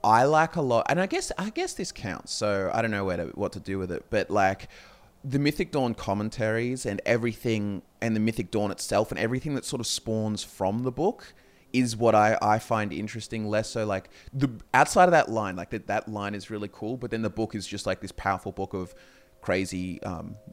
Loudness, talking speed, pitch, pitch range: -27 LUFS, 230 wpm, 110 Hz, 100-120 Hz